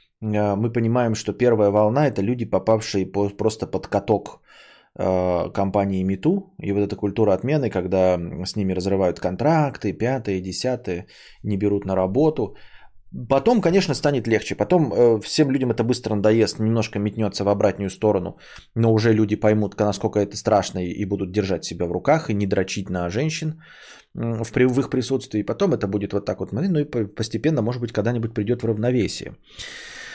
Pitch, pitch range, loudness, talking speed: 110 Hz, 100-125 Hz, -22 LUFS, 160 wpm